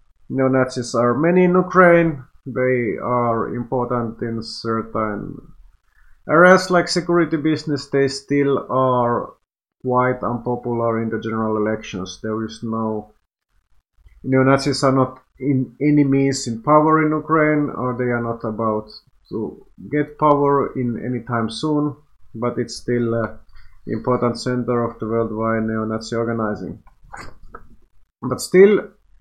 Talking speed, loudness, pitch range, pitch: 125 wpm, -19 LUFS, 115-140 Hz, 125 Hz